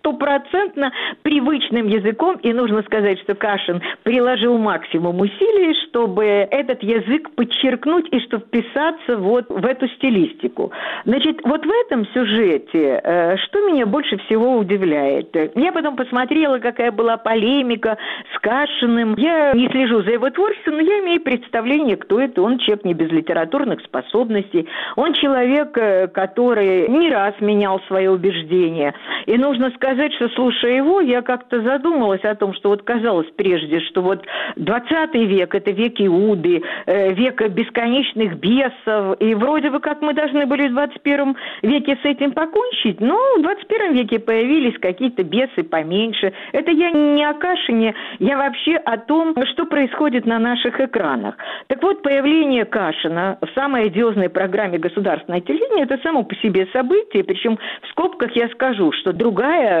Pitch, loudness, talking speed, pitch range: 245 Hz, -18 LUFS, 150 wpm, 210-290 Hz